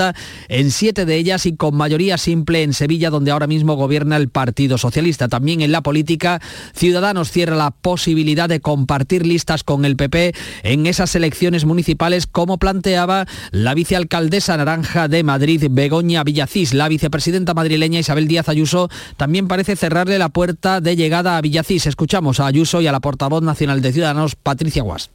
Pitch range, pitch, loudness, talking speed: 150-175 Hz, 160 Hz, -16 LUFS, 170 wpm